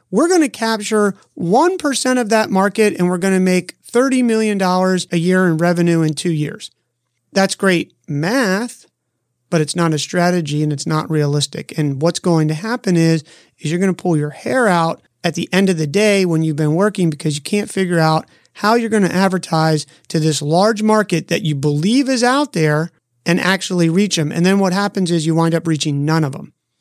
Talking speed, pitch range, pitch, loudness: 210 wpm, 155-205 Hz, 175 Hz, -16 LUFS